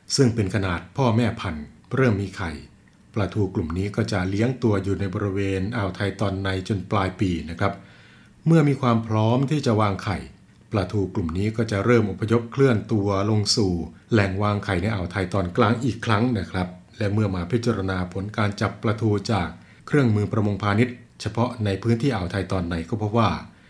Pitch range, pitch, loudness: 95-115 Hz, 105 Hz, -24 LUFS